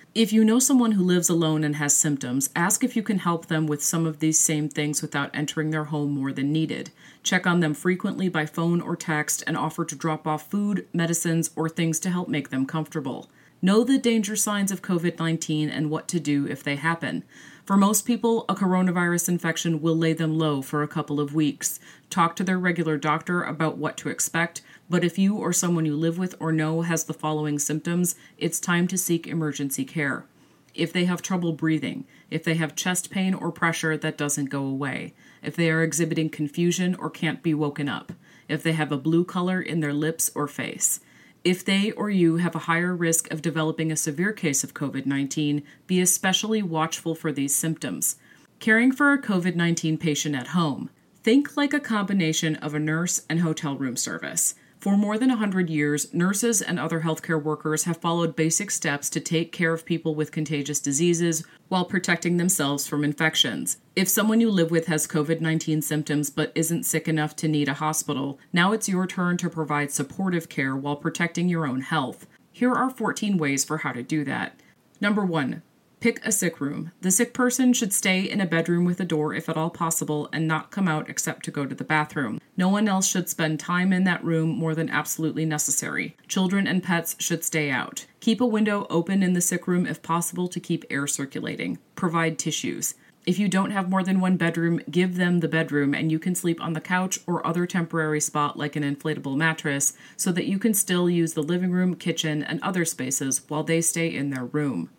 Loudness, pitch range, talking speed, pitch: -24 LUFS, 155-180 Hz, 210 wpm, 165 Hz